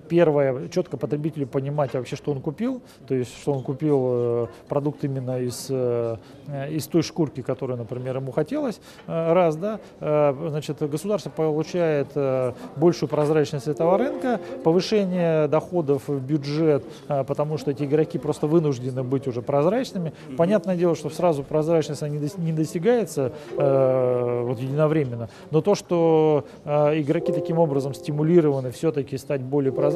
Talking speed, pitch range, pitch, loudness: 130 wpm, 135-165 Hz, 150 Hz, -24 LUFS